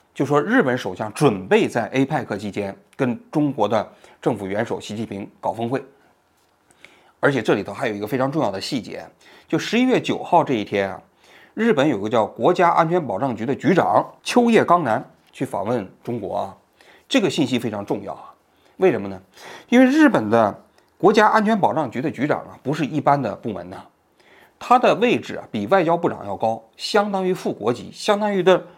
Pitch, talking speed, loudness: 150 Hz, 290 characters per minute, -20 LUFS